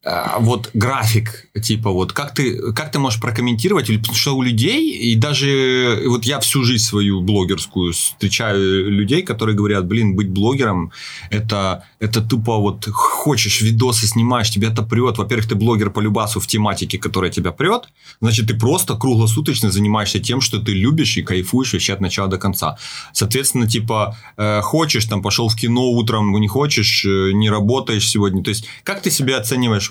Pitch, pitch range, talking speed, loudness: 110 Hz, 105-125 Hz, 170 wpm, -17 LUFS